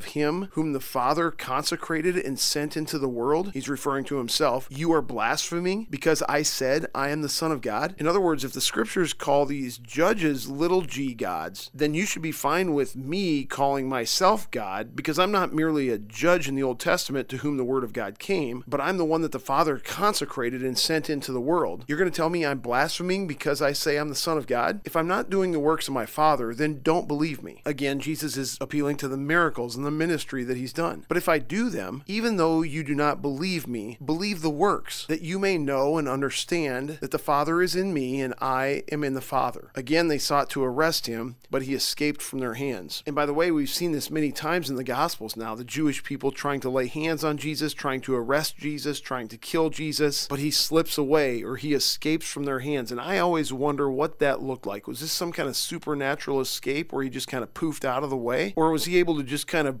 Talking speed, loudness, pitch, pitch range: 240 wpm, -26 LUFS, 145 Hz, 135-160 Hz